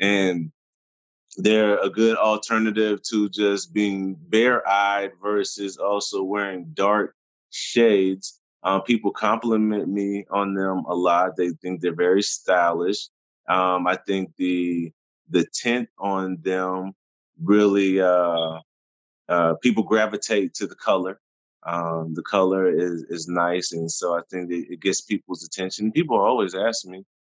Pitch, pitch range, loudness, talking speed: 95 Hz, 90-105 Hz, -22 LUFS, 135 wpm